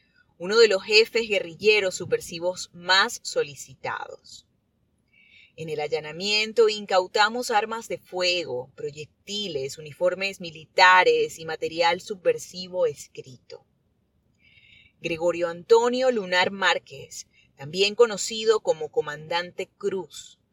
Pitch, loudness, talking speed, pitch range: 185 Hz, -23 LUFS, 90 wpm, 170-230 Hz